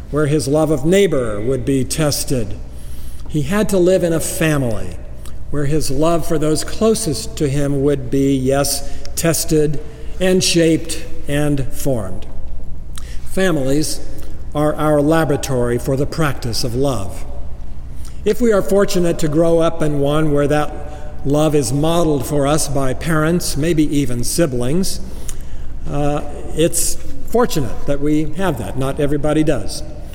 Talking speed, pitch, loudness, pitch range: 140 wpm, 145 Hz, -17 LUFS, 125-160 Hz